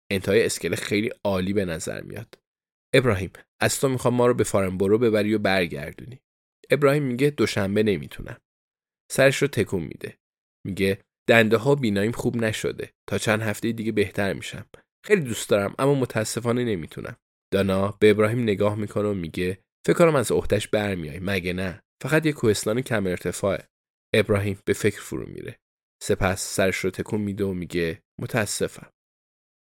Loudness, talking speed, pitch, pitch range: -23 LUFS, 155 wpm, 105 Hz, 95-115 Hz